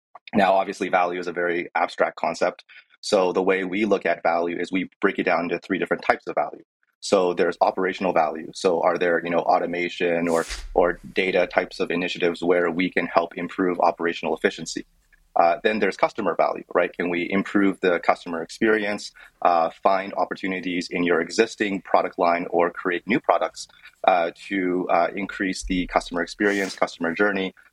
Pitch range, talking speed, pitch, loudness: 85-95 Hz, 175 wpm, 90 Hz, -23 LUFS